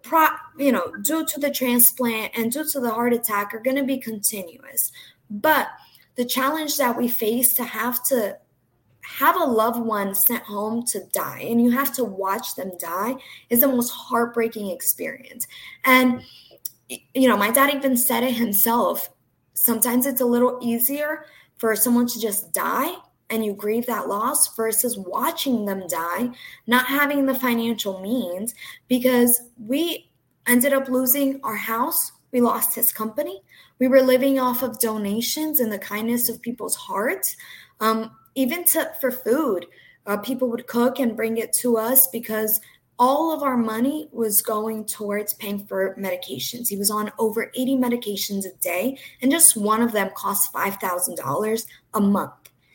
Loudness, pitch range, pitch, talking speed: -21 LUFS, 220-260 Hz, 240 Hz, 165 wpm